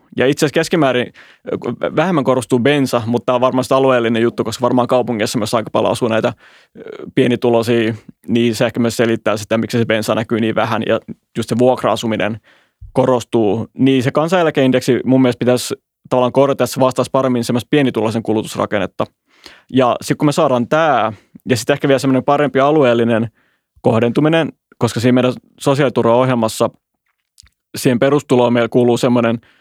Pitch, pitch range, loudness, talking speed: 125 Hz, 115-135 Hz, -15 LUFS, 155 wpm